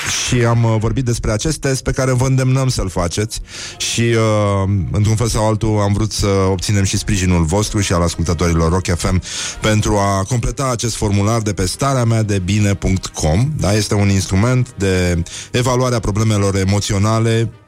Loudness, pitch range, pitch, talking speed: -16 LUFS, 95-115 Hz, 105 Hz, 165 wpm